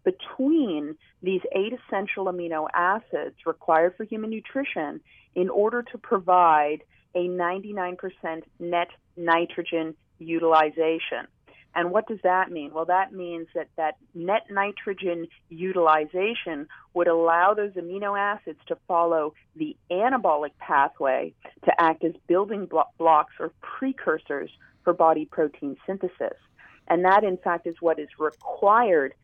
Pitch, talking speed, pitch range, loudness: 175 Hz, 125 wpm, 165-200 Hz, -25 LUFS